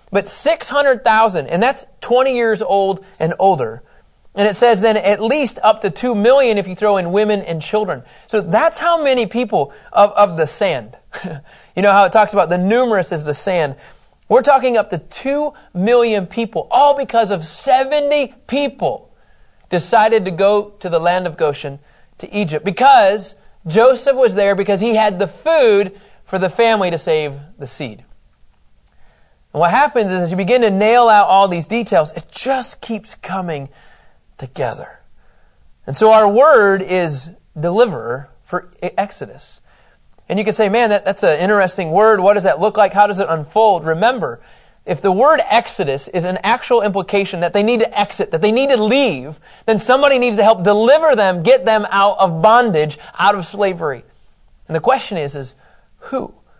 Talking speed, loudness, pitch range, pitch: 180 wpm, -15 LUFS, 185-235 Hz, 205 Hz